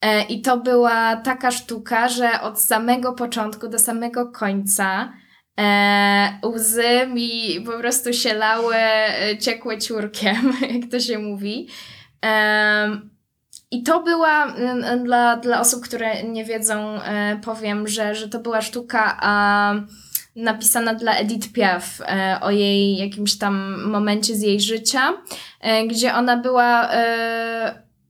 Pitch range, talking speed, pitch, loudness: 210-240 Hz, 130 wpm, 225 Hz, -19 LUFS